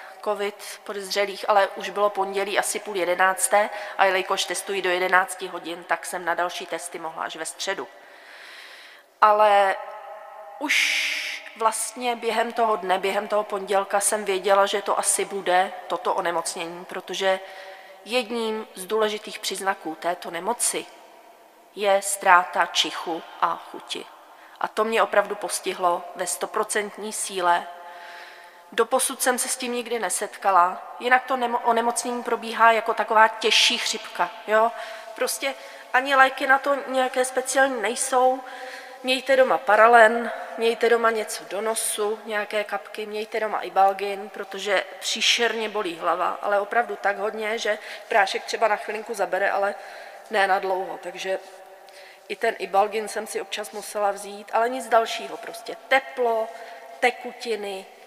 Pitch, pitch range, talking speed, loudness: 210 Hz, 190-230 Hz, 140 wpm, -23 LUFS